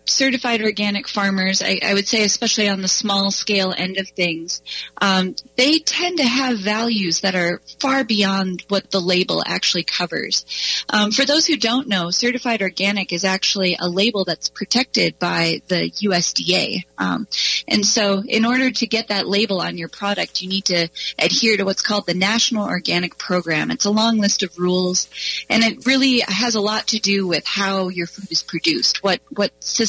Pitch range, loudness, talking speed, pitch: 185-225 Hz, -18 LUFS, 185 wpm, 200 Hz